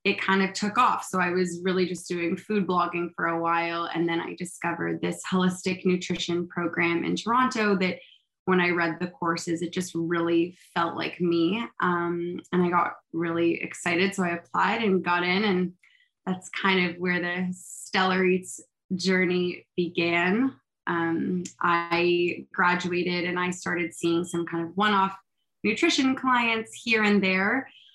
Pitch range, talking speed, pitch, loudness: 170-190 Hz, 165 wpm, 180 Hz, -26 LUFS